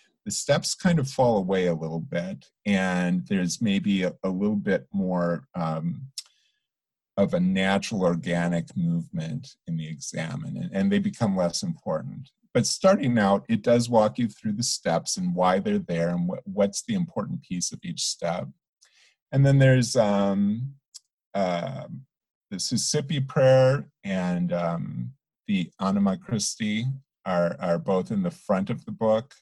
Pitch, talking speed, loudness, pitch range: 110 Hz, 155 wpm, -25 LUFS, 90-155 Hz